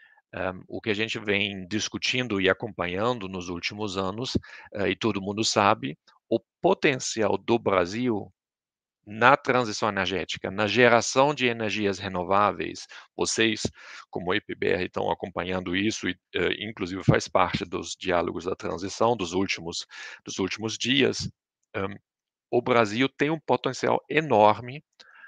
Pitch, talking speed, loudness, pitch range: 110 Hz, 135 wpm, -26 LUFS, 95-120 Hz